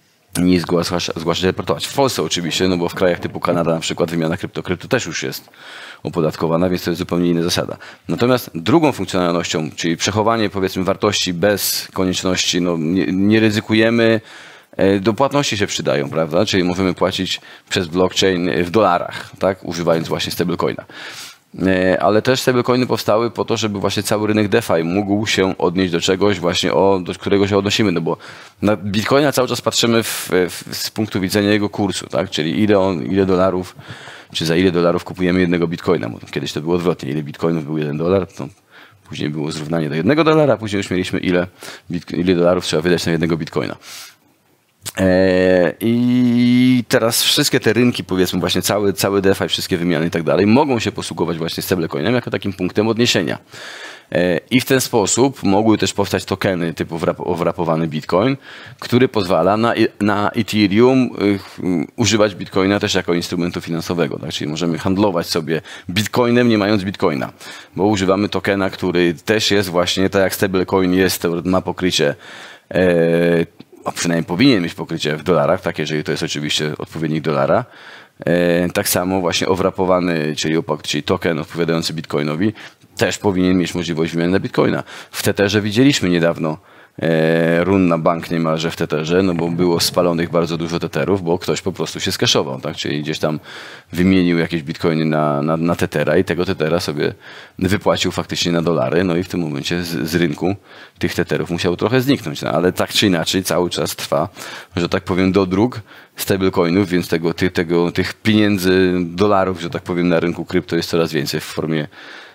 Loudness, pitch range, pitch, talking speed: -17 LUFS, 85-100 Hz, 90 Hz, 175 wpm